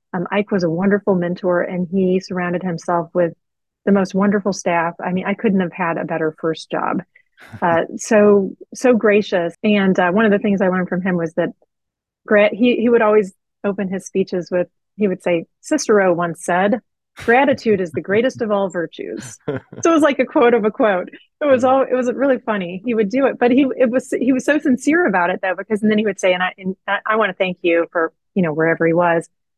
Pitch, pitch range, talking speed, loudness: 195 Hz, 175-225 Hz, 230 wpm, -18 LUFS